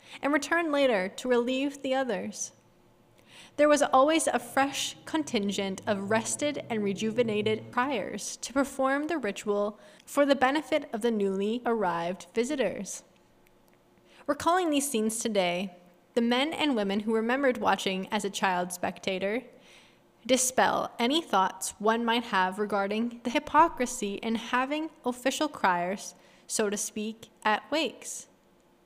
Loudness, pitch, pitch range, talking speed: -28 LUFS, 230 Hz, 200-270 Hz, 130 wpm